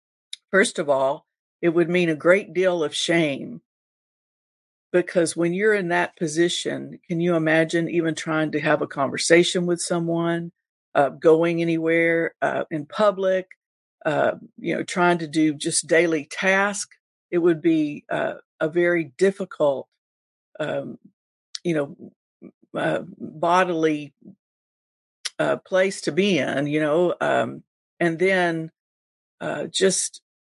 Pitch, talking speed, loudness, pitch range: 170 Hz, 130 wpm, -22 LUFS, 155-185 Hz